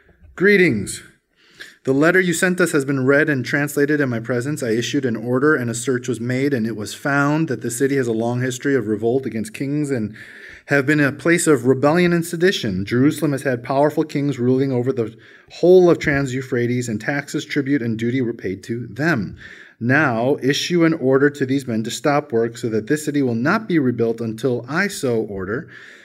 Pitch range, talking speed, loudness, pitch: 120-150 Hz, 205 wpm, -19 LUFS, 135 Hz